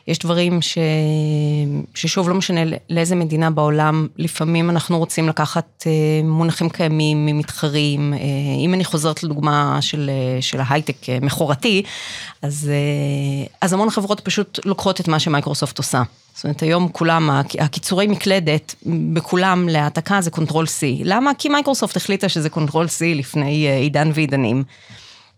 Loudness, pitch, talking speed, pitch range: -18 LUFS, 155 Hz, 130 wpm, 145-170 Hz